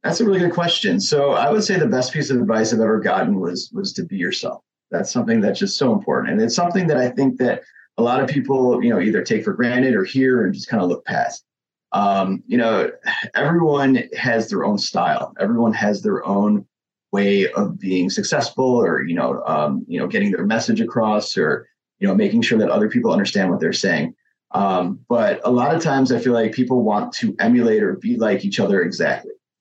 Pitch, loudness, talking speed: 150 Hz, -19 LUFS, 225 wpm